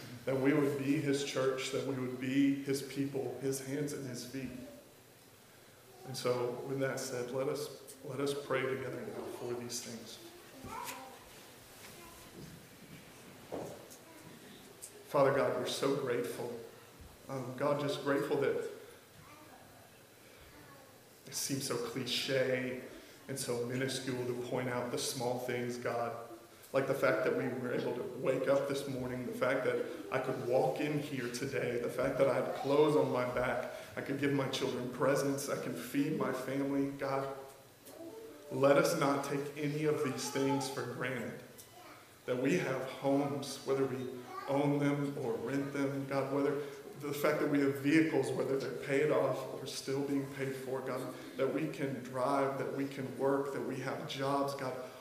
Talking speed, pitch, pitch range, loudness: 165 wpm, 135 Hz, 130-140 Hz, -35 LUFS